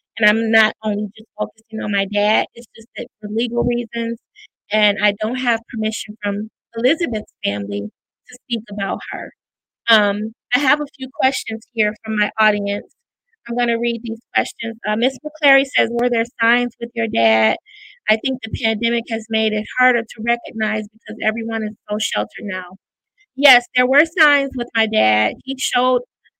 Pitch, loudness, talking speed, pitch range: 225 Hz, -18 LUFS, 175 wpm, 210-245 Hz